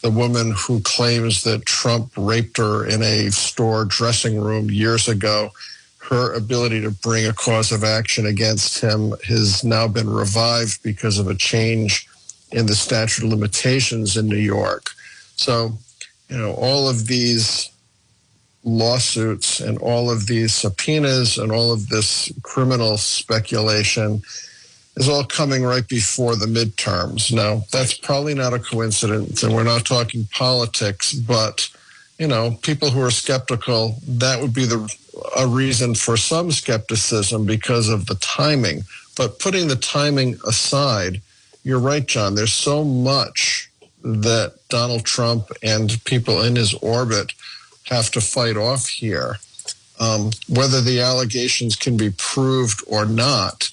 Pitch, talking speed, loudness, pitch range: 115 Hz, 145 wpm, -18 LUFS, 110-125 Hz